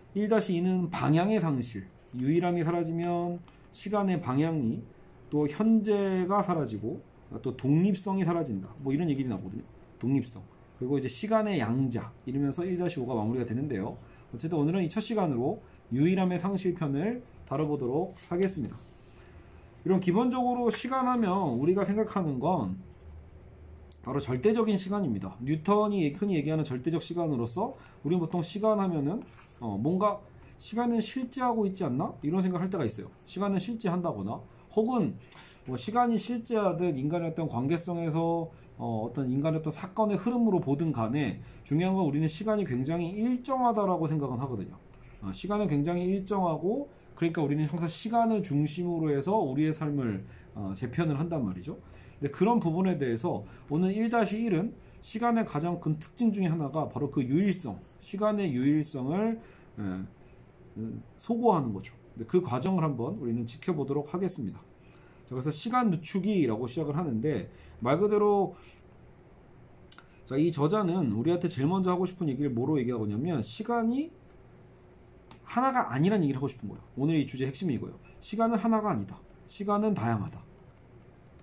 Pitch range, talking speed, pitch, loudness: 135-200 Hz, 340 characters per minute, 170 Hz, -30 LUFS